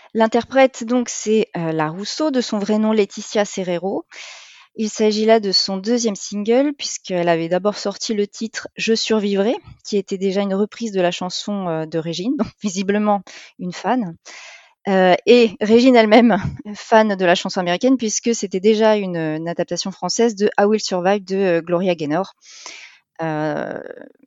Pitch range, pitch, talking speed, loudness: 185-225 Hz, 205 Hz, 165 wpm, -18 LUFS